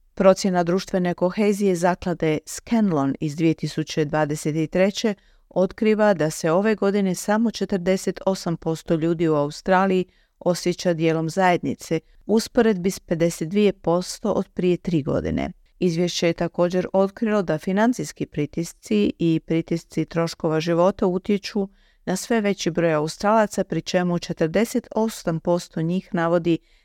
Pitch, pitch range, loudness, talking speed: 180 Hz, 165-195 Hz, -22 LUFS, 120 wpm